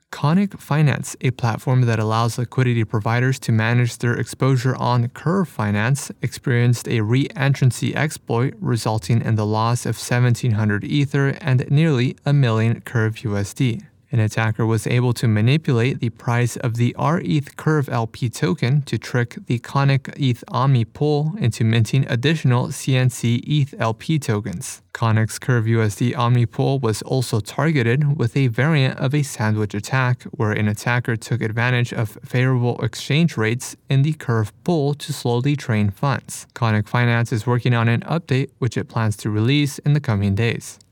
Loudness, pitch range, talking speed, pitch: -20 LUFS, 115-140 Hz, 160 wpm, 125 Hz